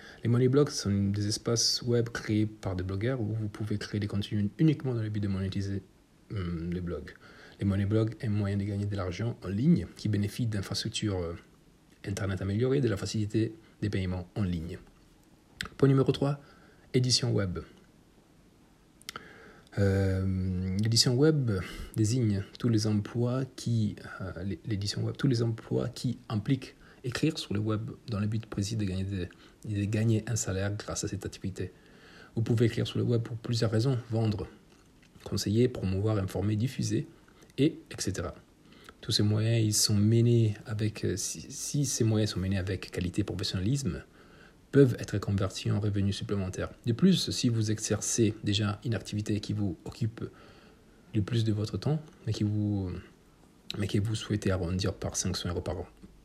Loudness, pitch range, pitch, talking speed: -30 LUFS, 100-115 Hz, 105 Hz, 165 wpm